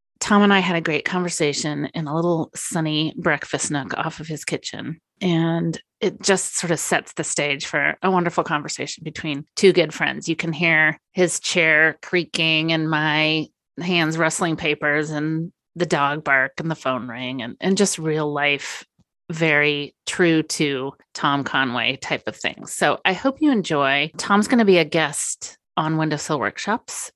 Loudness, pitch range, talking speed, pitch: -21 LUFS, 150-175 Hz, 175 wpm, 160 Hz